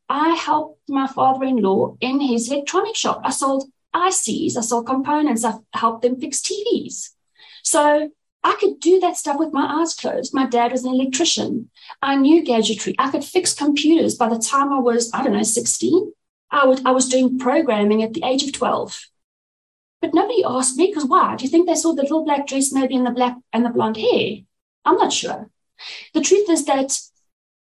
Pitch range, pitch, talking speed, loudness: 255-330 Hz, 275 Hz, 200 wpm, -19 LUFS